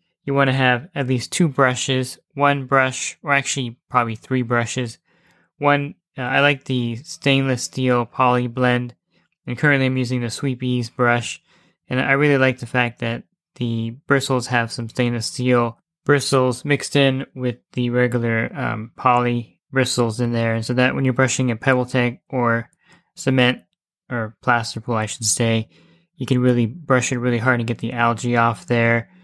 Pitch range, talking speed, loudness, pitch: 120-135 Hz, 175 wpm, -20 LUFS, 125 Hz